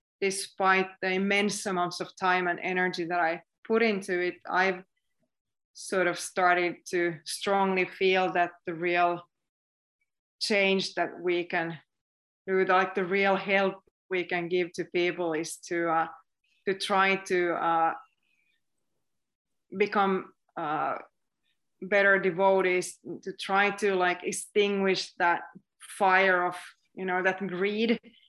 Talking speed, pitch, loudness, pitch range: 125 wpm, 185 Hz, -27 LUFS, 175-195 Hz